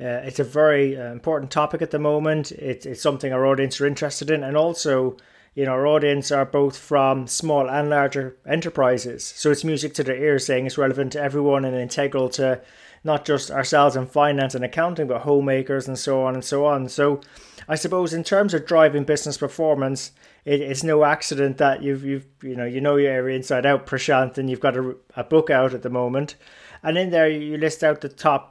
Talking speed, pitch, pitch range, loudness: 215 wpm, 140 Hz, 130-150 Hz, -21 LUFS